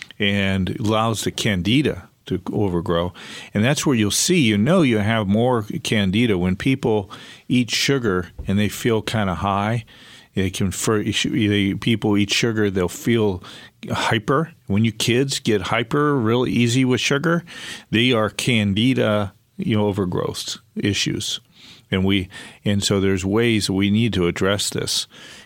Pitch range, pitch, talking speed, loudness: 100-125 Hz, 105 Hz, 145 wpm, -20 LUFS